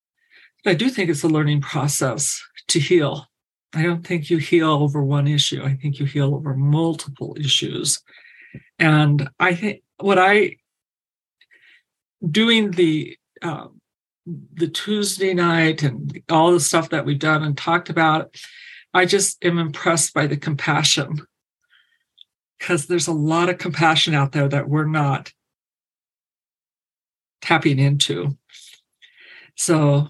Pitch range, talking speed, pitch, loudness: 145-175 Hz, 130 wpm, 160 Hz, -19 LUFS